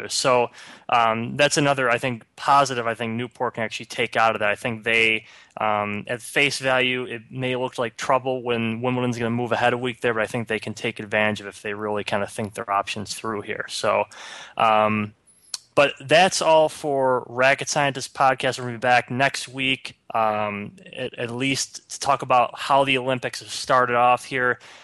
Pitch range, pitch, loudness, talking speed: 110-130 Hz, 120 Hz, -22 LUFS, 205 wpm